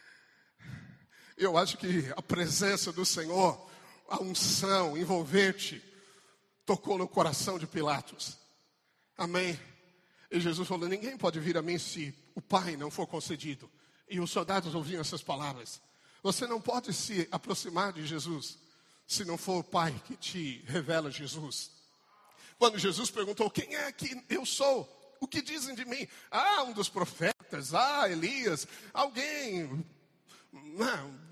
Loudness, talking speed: -33 LUFS, 140 wpm